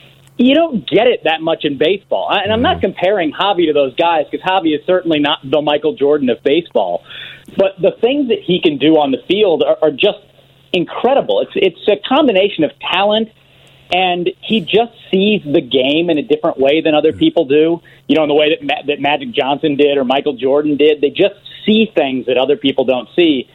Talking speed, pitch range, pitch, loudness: 215 wpm, 145-195 Hz, 160 Hz, -14 LUFS